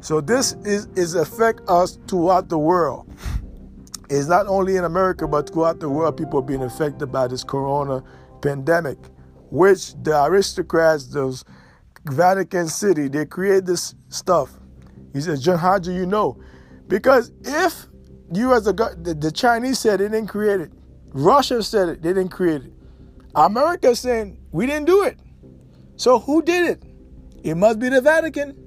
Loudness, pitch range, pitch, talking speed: -20 LUFS, 140-210 Hz, 175 Hz, 165 wpm